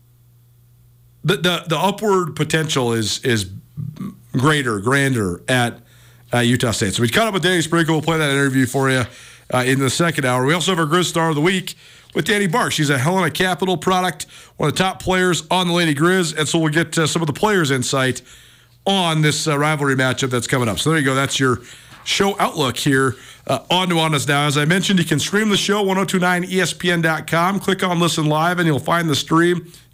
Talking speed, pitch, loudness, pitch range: 215 wpm, 155 Hz, -18 LUFS, 130-180 Hz